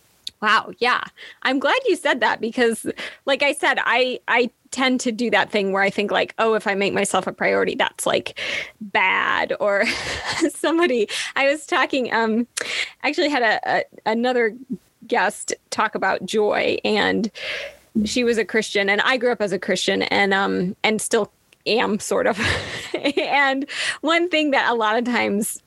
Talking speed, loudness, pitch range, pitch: 175 wpm, -20 LUFS, 210-280 Hz, 235 Hz